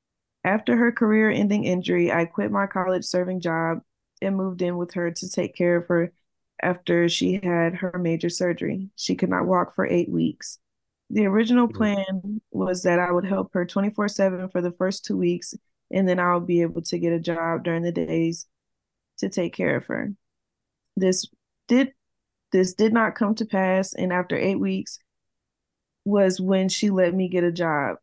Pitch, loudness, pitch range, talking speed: 185 Hz, -24 LUFS, 175-200 Hz, 185 wpm